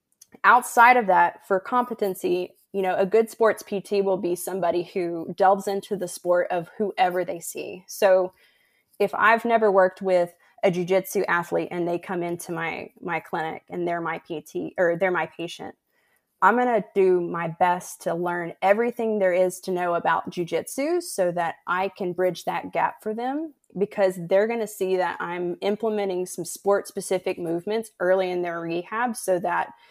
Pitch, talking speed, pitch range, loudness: 185 Hz, 175 wpm, 175-205 Hz, -24 LUFS